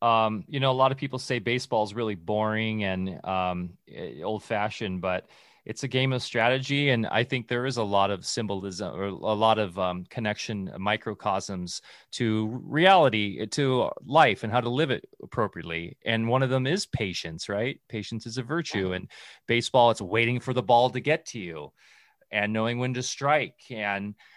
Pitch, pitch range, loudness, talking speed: 110 Hz, 100-130 Hz, -27 LUFS, 185 wpm